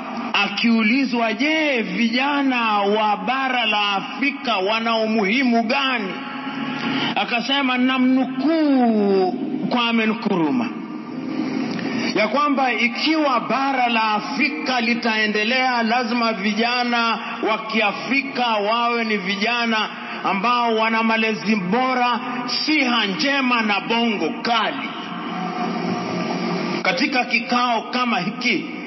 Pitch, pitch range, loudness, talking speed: 240 Hz, 220-265 Hz, -19 LUFS, 85 wpm